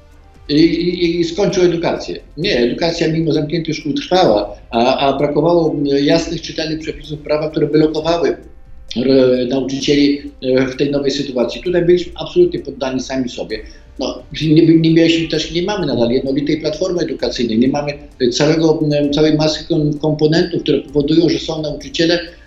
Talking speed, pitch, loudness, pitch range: 145 wpm, 150 Hz, -15 LUFS, 135-165 Hz